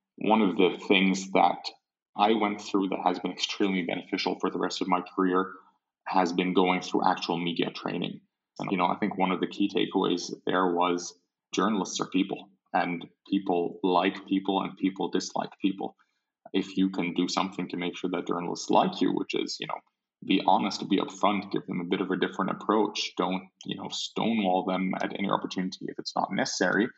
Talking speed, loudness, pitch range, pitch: 200 wpm, -28 LUFS, 90-95 Hz, 95 Hz